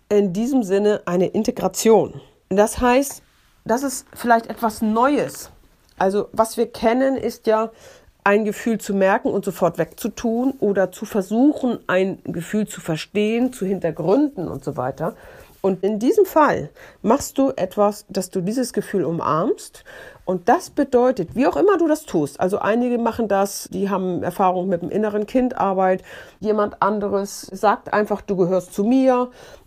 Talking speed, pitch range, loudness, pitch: 155 wpm, 190-235 Hz, -20 LUFS, 205 Hz